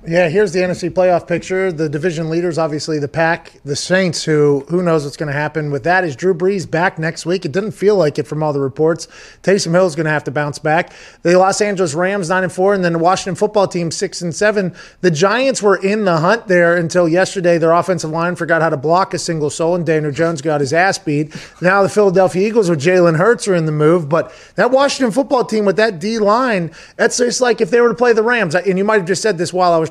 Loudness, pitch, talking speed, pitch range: -15 LUFS, 180 Hz, 255 wpm, 165-195 Hz